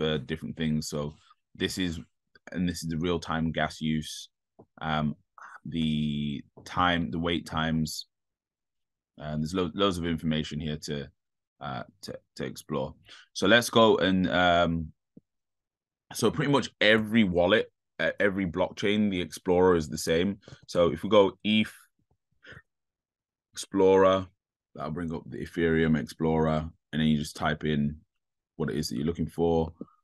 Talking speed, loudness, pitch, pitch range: 145 wpm, -27 LUFS, 80 Hz, 75-95 Hz